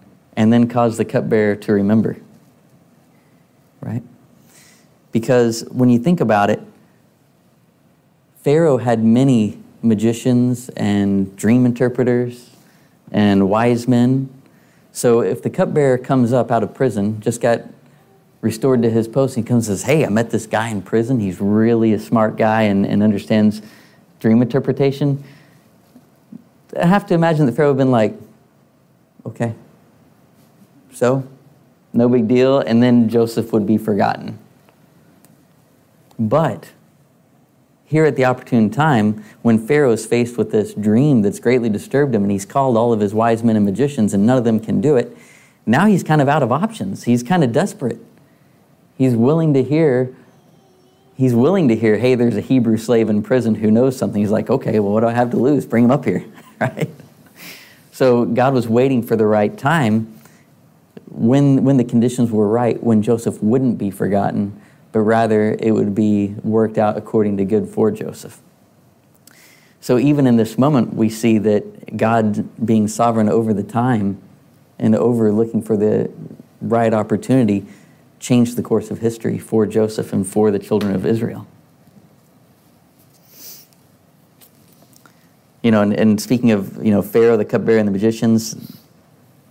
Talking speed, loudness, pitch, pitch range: 160 wpm, -16 LUFS, 115 Hz, 110-130 Hz